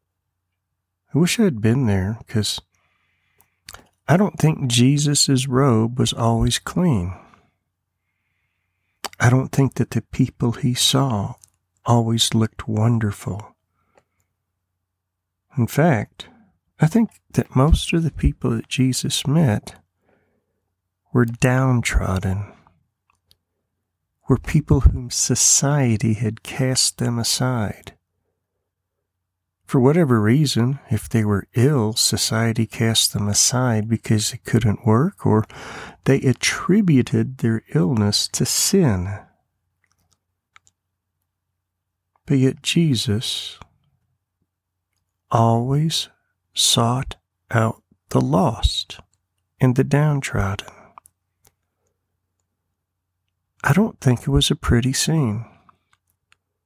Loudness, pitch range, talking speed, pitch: -19 LUFS, 95-130 Hz, 95 wpm, 110 Hz